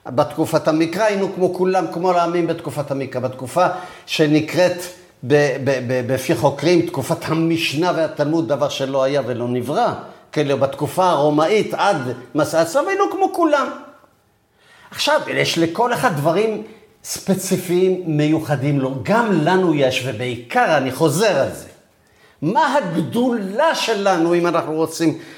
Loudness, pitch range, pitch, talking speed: -18 LUFS, 145-190 Hz, 165 Hz, 125 wpm